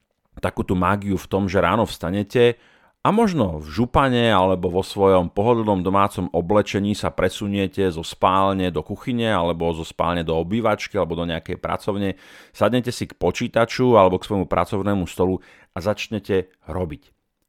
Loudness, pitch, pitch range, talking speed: -21 LUFS, 95 Hz, 90-105 Hz, 150 wpm